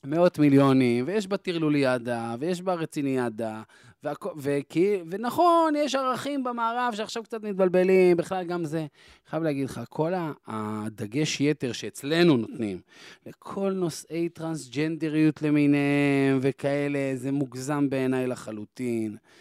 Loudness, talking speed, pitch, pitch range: -26 LUFS, 115 wpm, 150 Hz, 135-185 Hz